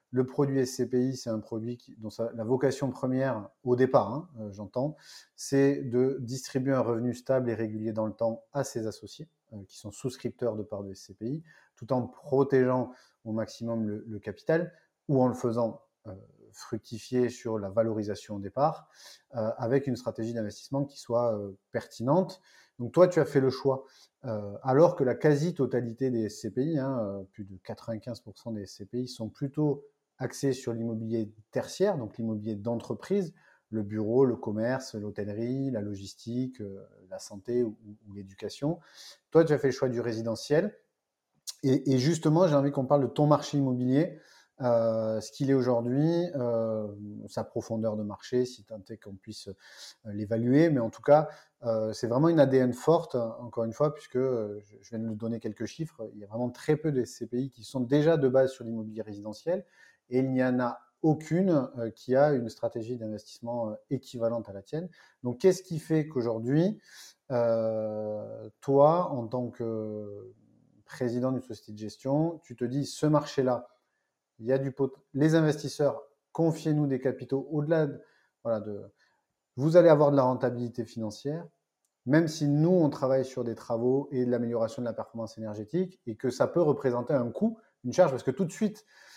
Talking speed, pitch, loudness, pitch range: 175 wpm, 125 Hz, -29 LUFS, 110-140 Hz